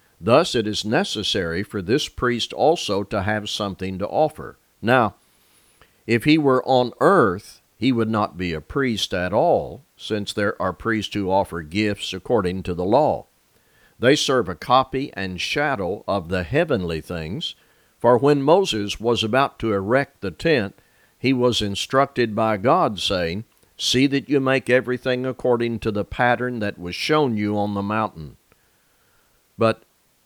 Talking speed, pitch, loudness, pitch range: 160 wpm, 110 Hz, -21 LUFS, 100-130 Hz